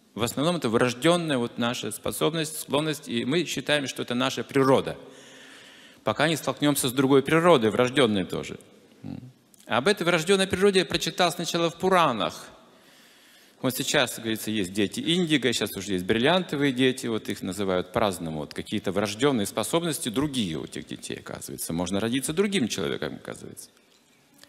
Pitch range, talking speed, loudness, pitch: 110-165 Hz, 155 wpm, -25 LUFS, 135 Hz